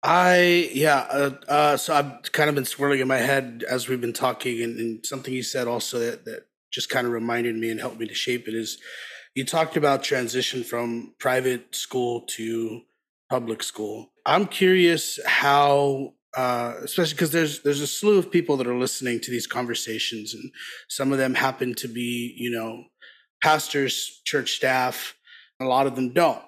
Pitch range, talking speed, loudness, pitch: 120-145 Hz, 190 wpm, -24 LUFS, 130 Hz